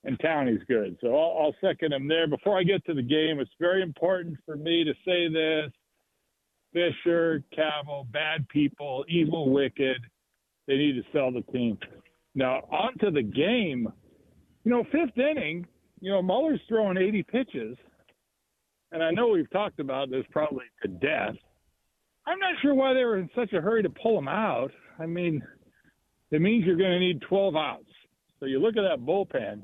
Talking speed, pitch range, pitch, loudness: 180 wpm, 150-195 Hz, 165 Hz, -27 LUFS